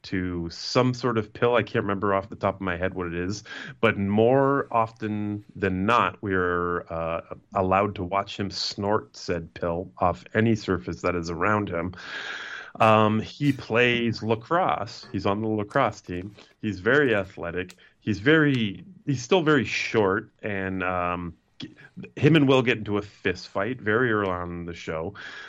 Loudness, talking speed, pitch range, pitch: -25 LUFS, 170 wpm, 90-115 Hz, 105 Hz